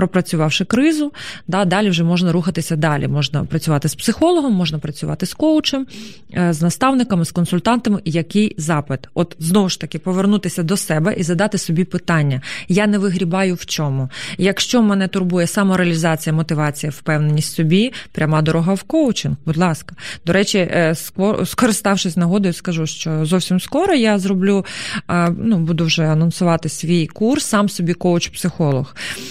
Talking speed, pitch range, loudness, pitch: 145 wpm, 160-200 Hz, -17 LUFS, 180 Hz